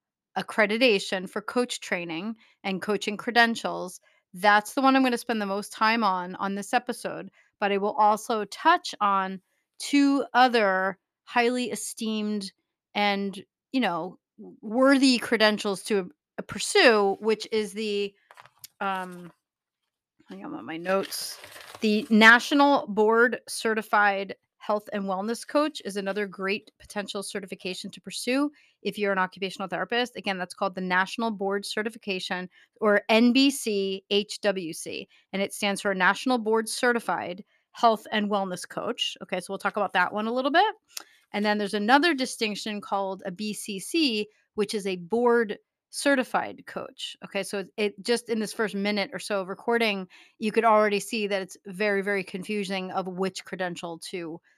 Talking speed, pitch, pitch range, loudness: 150 wpm, 205 Hz, 195-230 Hz, -26 LUFS